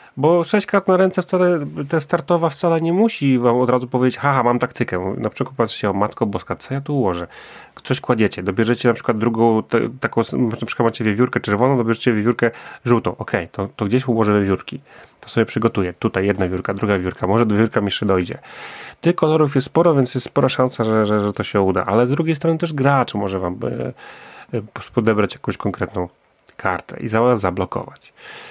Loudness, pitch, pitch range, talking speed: -19 LUFS, 120 Hz, 105-135 Hz, 200 wpm